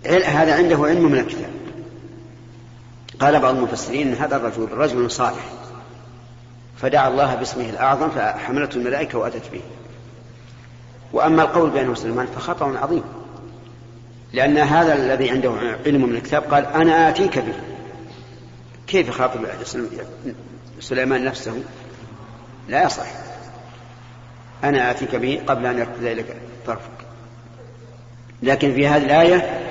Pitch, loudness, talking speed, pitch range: 120 Hz, -19 LUFS, 115 wpm, 120-135 Hz